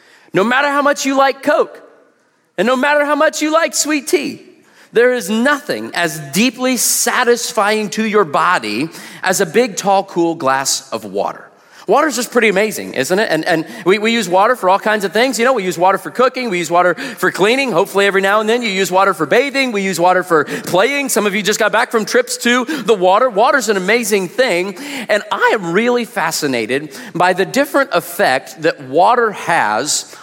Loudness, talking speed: -14 LUFS, 210 wpm